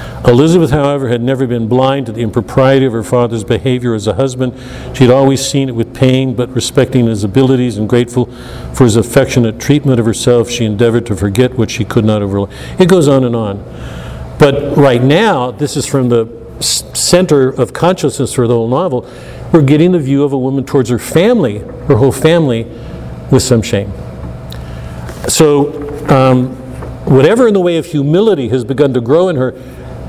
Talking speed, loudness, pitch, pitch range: 185 wpm, -11 LUFS, 125 Hz, 115-140 Hz